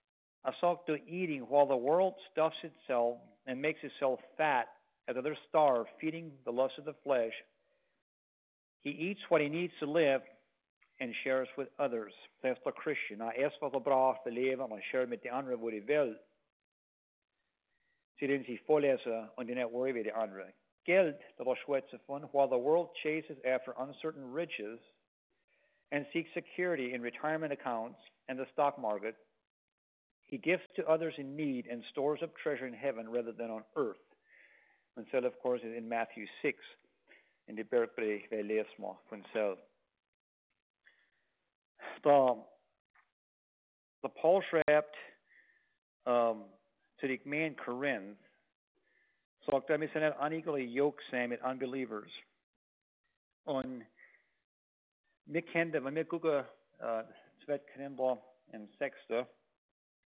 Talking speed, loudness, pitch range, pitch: 130 wpm, -35 LUFS, 120-155 Hz, 135 Hz